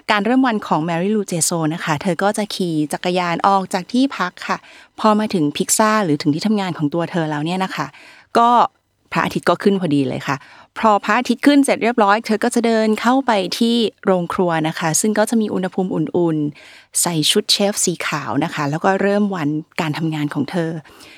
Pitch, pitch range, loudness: 190 Hz, 160-215 Hz, -18 LUFS